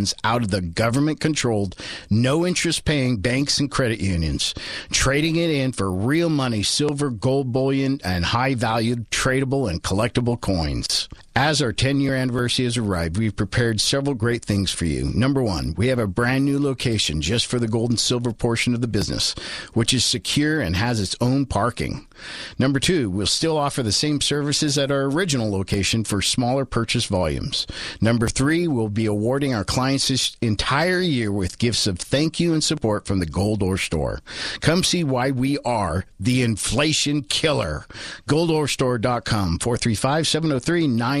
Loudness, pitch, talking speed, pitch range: -21 LUFS, 120 Hz, 165 wpm, 105-140 Hz